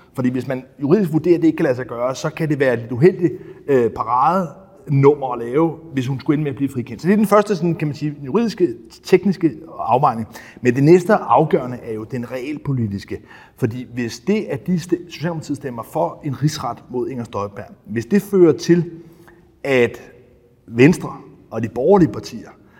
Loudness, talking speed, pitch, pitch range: -19 LUFS, 195 wpm, 145 Hz, 125-170 Hz